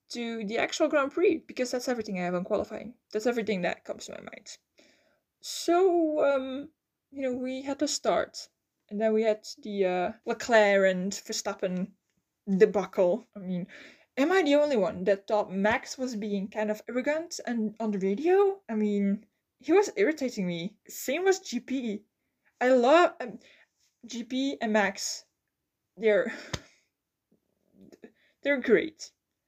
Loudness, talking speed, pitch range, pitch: -28 LUFS, 150 wpm, 205-280 Hz, 230 Hz